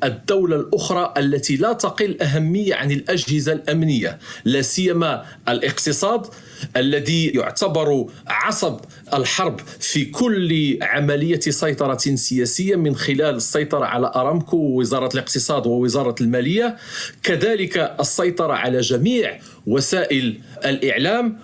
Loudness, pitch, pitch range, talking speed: -19 LUFS, 150 Hz, 135-180 Hz, 100 wpm